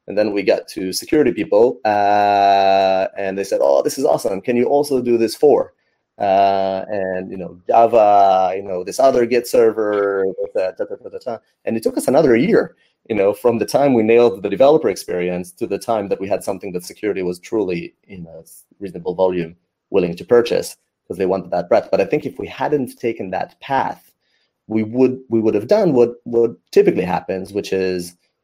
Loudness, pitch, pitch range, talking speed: -17 LUFS, 105 Hz, 95-120 Hz, 200 wpm